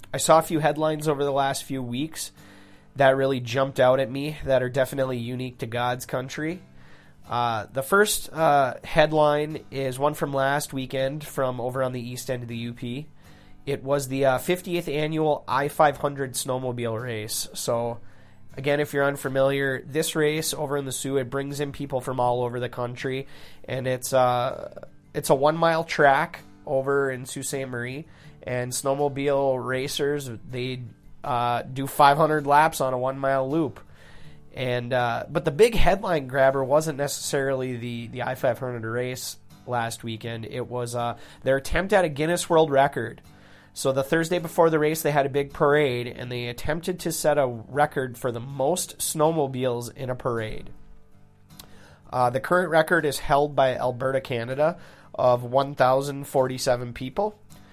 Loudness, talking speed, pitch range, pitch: -25 LUFS, 165 wpm, 125-150 Hz, 135 Hz